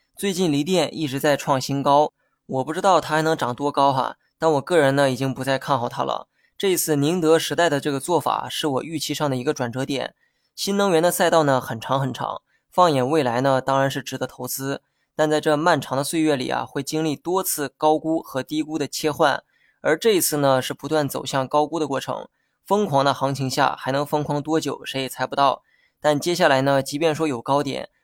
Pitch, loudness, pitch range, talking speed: 145 Hz, -22 LUFS, 135-160 Hz, 310 characters per minute